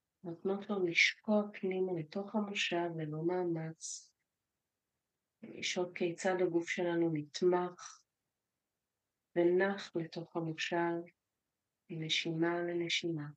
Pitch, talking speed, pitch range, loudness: 175 Hz, 80 wpm, 165-185 Hz, -35 LUFS